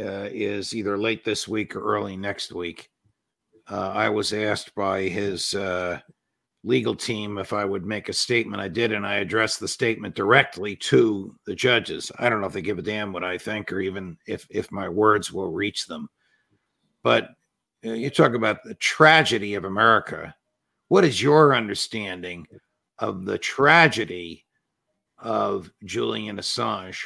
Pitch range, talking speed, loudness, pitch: 95-110 Hz, 165 wpm, -23 LUFS, 105 Hz